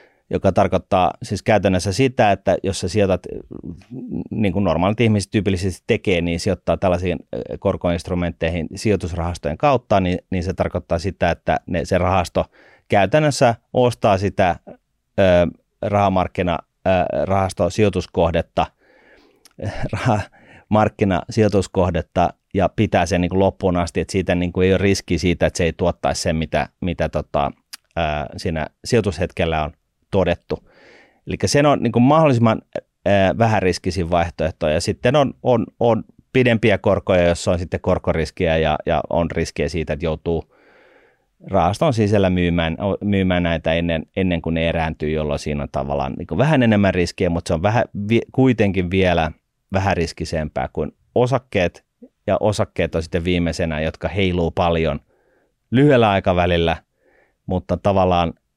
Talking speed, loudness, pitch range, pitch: 130 wpm, -19 LUFS, 85-100 Hz, 90 Hz